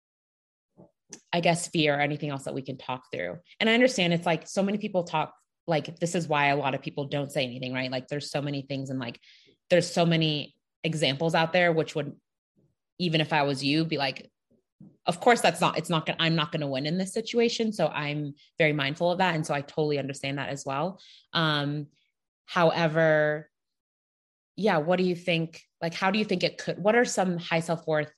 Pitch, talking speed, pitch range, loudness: 160 Hz, 215 wpm, 145-175 Hz, -27 LUFS